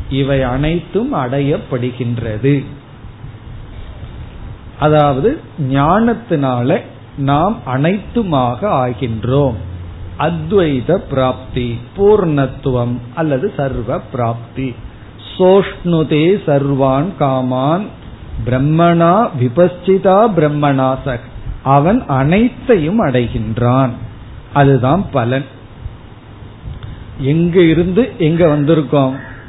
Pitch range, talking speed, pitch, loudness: 120-155 Hz, 60 wpm, 135 Hz, -14 LUFS